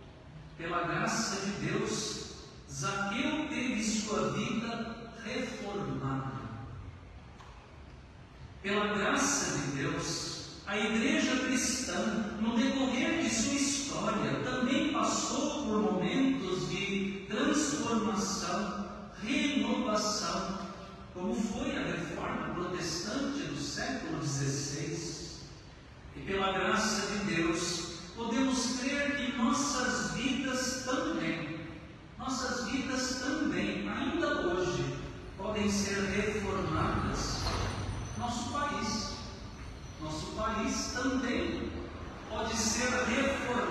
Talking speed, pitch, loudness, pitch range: 85 wpm, 220 Hz, -33 LUFS, 180-255 Hz